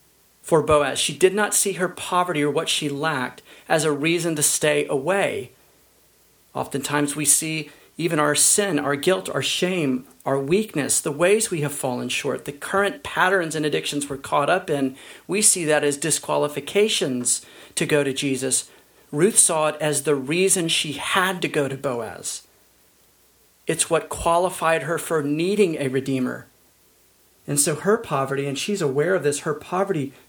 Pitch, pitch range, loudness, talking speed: 150 Hz, 145-175 Hz, -21 LUFS, 170 wpm